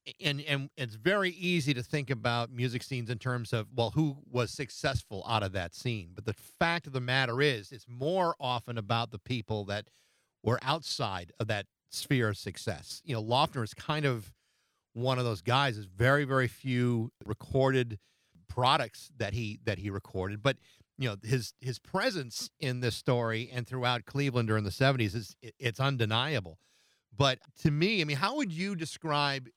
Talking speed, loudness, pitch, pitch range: 185 wpm, -32 LUFS, 125 Hz, 110-140 Hz